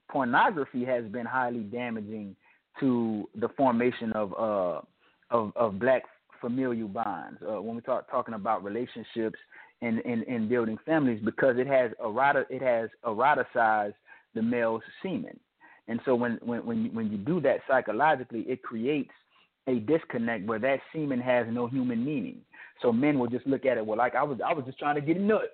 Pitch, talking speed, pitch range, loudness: 125 Hz, 180 wpm, 115-145 Hz, -29 LUFS